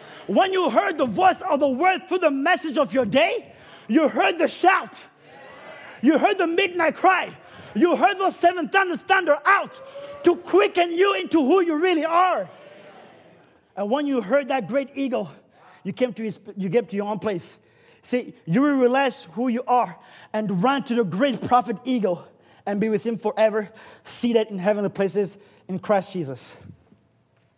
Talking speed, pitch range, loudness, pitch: 175 wpm, 210-345 Hz, -22 LUFS, 270 Hz